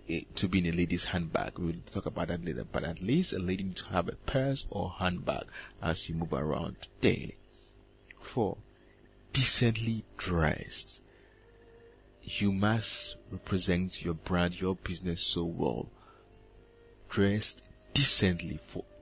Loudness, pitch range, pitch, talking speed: -30 LUFS, 90-110 Hz, 95 Hz, 135 wpm